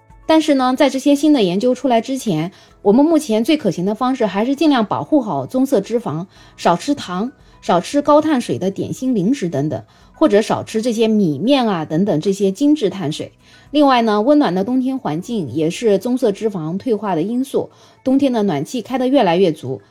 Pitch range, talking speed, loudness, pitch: 195-270 Hz, 300 characters per minute, -17 LUFS, 235 Hz